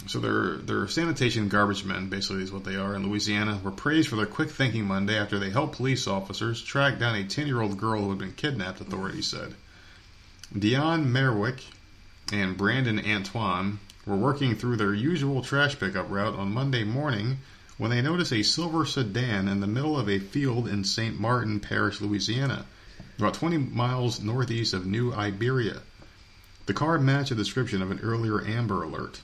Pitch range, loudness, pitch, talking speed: 100-130 Hz, -27 LUFS, 105 Hz, 180 wpm